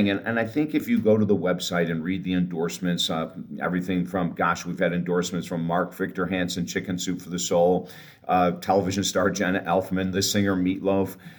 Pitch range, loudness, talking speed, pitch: 90-95 Hz, -25 LUFS, 200 wpm, 90 Hz